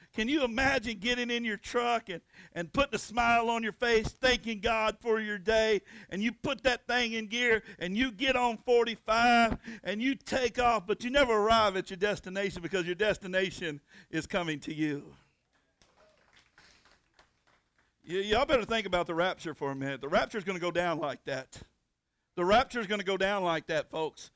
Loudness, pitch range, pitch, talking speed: -30 LUFS, 180-235 Hz, 215 Hz, 195 wpm